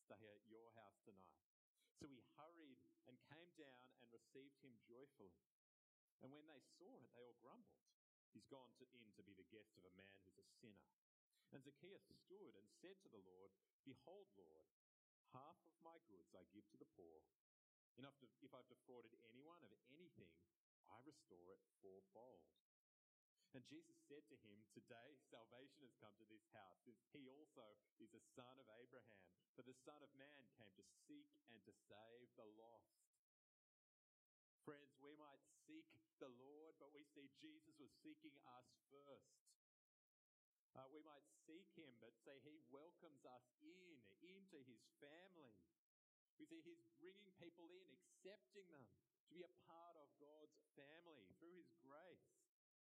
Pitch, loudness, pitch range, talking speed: 135 Hz, -68 LUFS, 110-170 Hz, 165 wpm